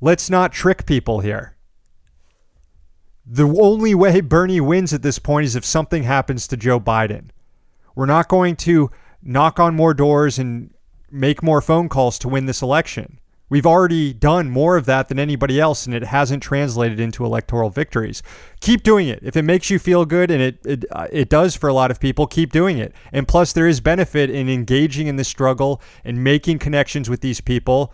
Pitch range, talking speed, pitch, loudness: 130-165 Hz, 200 wpm, 145 Hz, -17 LUFS